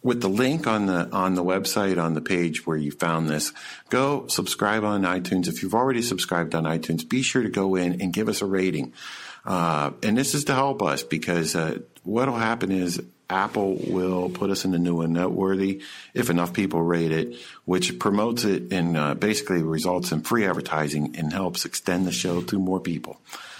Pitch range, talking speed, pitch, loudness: 85-100 Hz, 205 wpm, 90 Hz, -24 LUFS